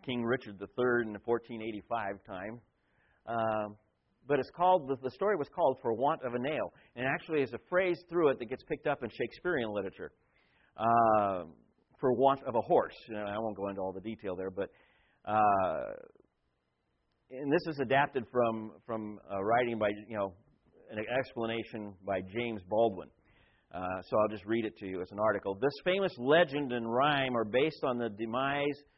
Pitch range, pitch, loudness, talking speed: 105-135 Hz, 115 Hz, -33 LUFS, 185 wpm